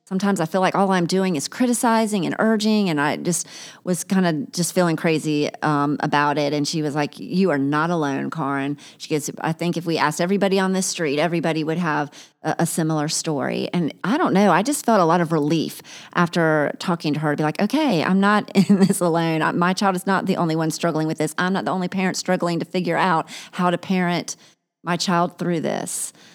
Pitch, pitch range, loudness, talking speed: 170 Hz, 155-190 Hz, -21 LUFS, 230 wpm